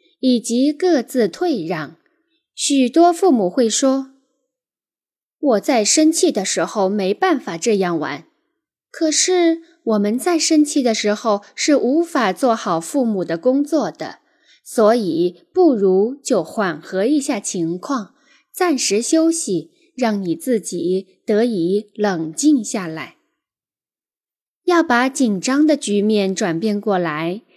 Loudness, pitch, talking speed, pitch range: -18 LUFS, 245 Hz, 180 characters per minute, 205-310 Hz